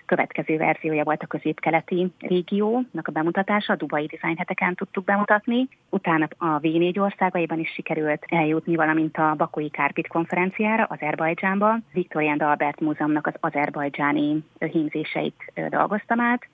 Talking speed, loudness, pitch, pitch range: 125 wpm, -24 LUFS, 165 Hz, 155-190 Hz